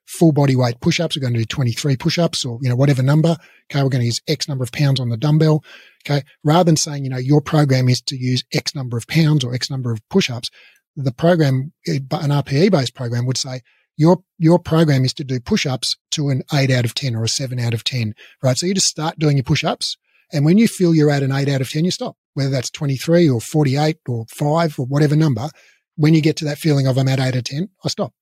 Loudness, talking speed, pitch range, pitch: -18 LUFS, 255 wpm, 130-160 Hz, 145 Hz